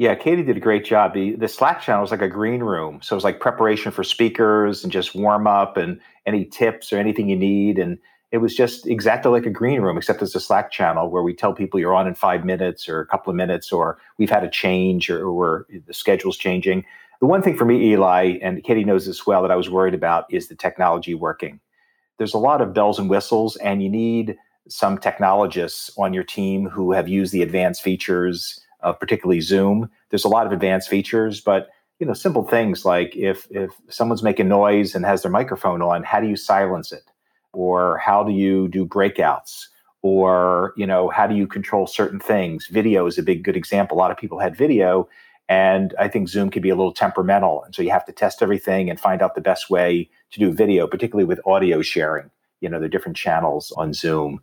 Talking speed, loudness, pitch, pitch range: 225 wpm, -19 LUFS, 95 Hz, 90-105 Hz